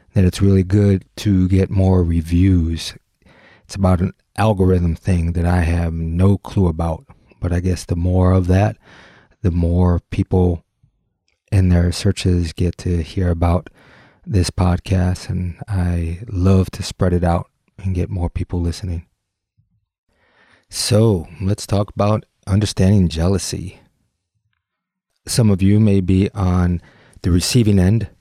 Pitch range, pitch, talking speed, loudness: 85-100 Hz, 95 Hz, 140 wpm, -18 LUFS